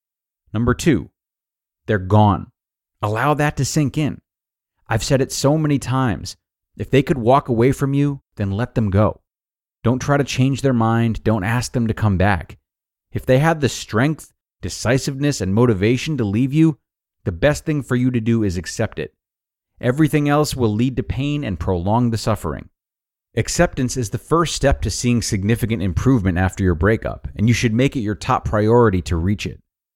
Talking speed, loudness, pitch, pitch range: 185 wpm, -19 LUFS, 115 Hz, 105-135 Hz